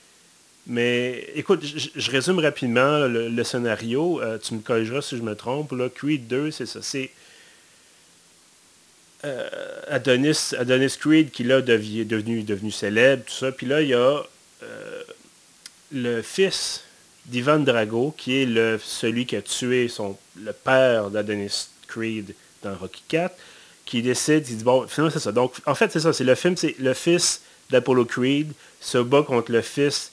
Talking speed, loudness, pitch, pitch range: 170 wpm, -23 LUFS, 130 Hz, 115-150 Hz